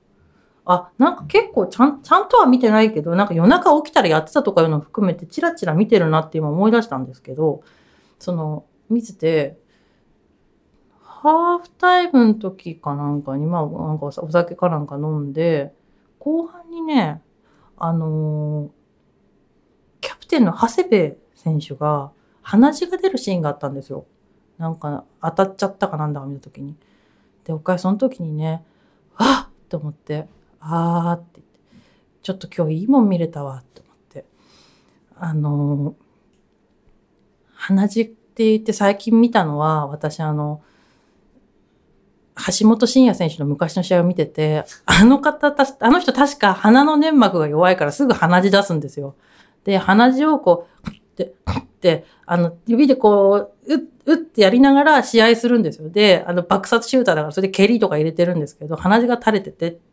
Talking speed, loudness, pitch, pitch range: 320 characters per minute, -17 LUFS, 180 Hz, 155-235 Hz